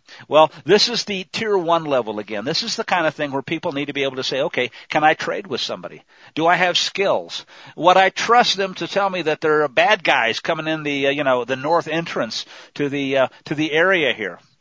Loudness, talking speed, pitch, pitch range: -19 LUFS, 245 wpm, 160 Hz, 145-185 Hz